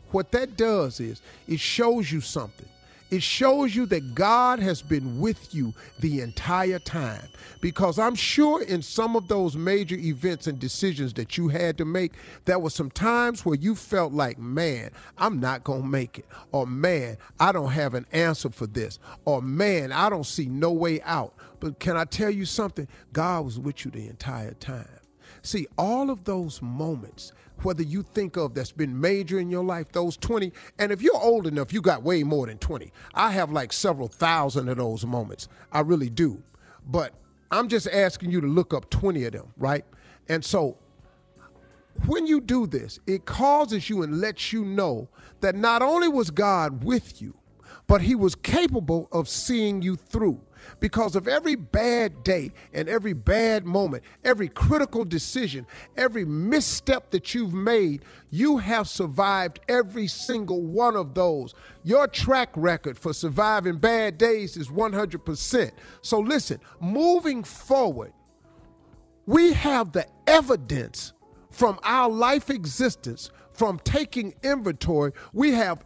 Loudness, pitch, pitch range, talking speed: -25 LUFS, 180 Hz, 145-225 Hz, 165 wpm